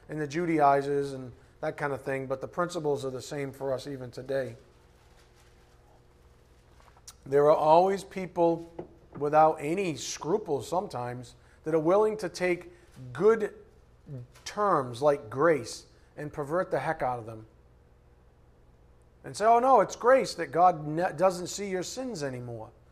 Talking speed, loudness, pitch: 145 wpm, -28 LUFS, 140 Hz